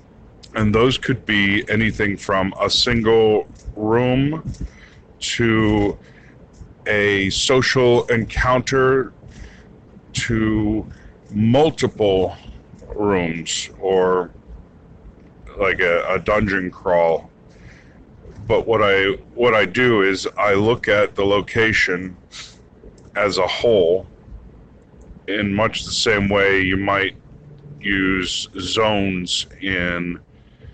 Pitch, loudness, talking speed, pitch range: 105 Hz, -18 LUFS, 90 wpm, 95-115 Hz